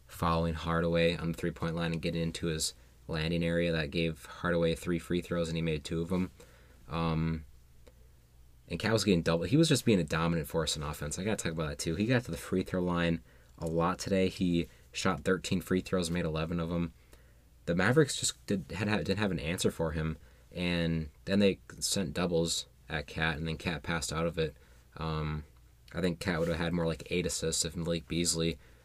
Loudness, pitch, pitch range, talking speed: -32 LUFS, 85 Hz, 80-85 Hz, 220 wpm